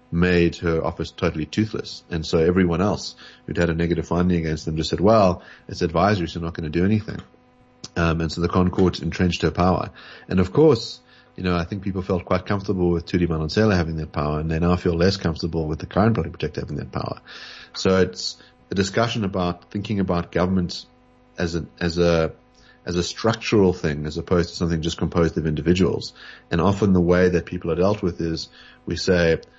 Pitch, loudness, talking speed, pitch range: 85 Hz, -22 LUFS, 210 wpm, 85-95 Hz